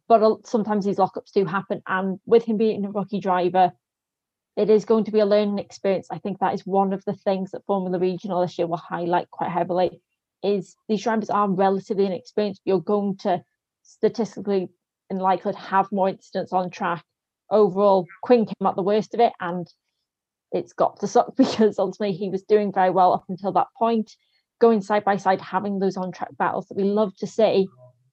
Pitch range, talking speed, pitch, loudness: 185-210 Hz, 195 wpm, 195 Hz, -23 LUFS